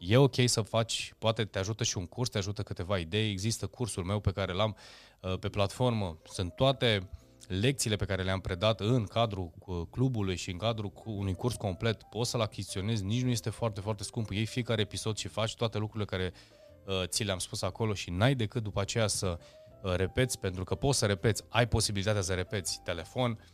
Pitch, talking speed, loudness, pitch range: 105 Hz, 195 wpm, -32 LUFS, 95-115 Hz